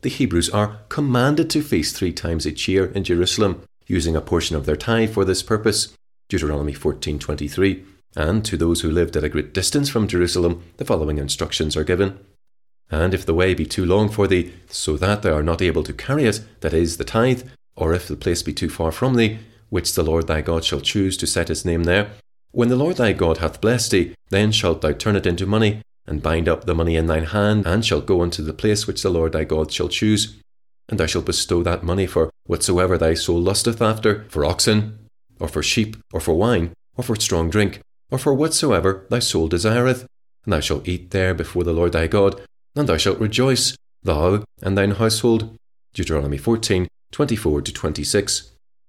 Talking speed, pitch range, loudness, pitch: 210 wpm, 85-110 Hz, -20 LUFS, 95 Hz